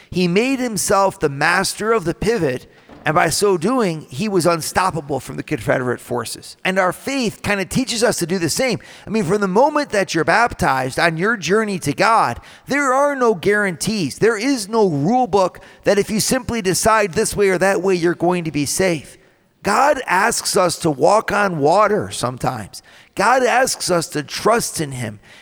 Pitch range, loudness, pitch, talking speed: 165-215 Hz, -18 LUFS, 190 Hz, 195 wpm